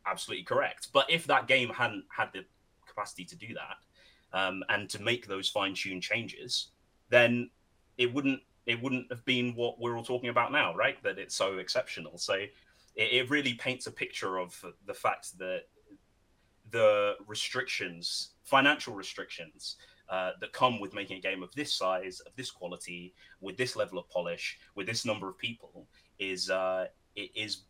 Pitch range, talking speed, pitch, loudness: 95-125 Hz, 175 wpm, 110 Hz, -31 LUFS